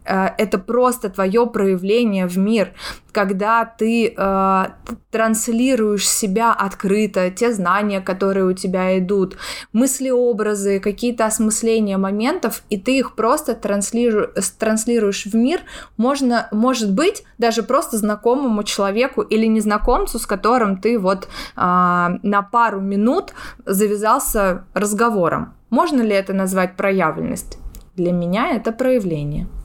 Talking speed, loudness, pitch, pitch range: 120 wpm, -18 LUFS, 215 Hz, 195-235 Hz